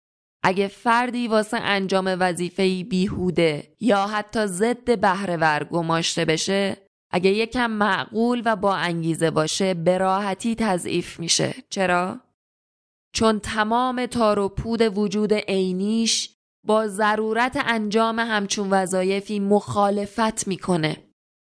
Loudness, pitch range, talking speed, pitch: -22 LUFS, 185-220 Hz, 105 wpm, 200 Hz